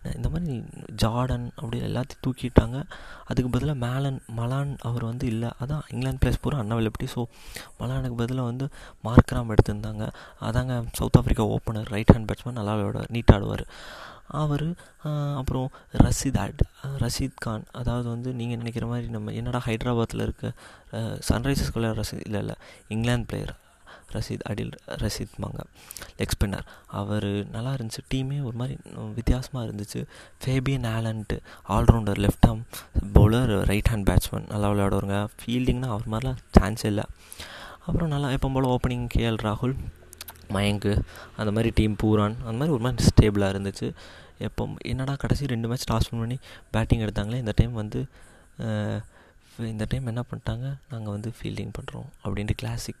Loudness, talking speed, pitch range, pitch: -27 LUFS, 140 wpm, 105-125 Hz, 115 Hz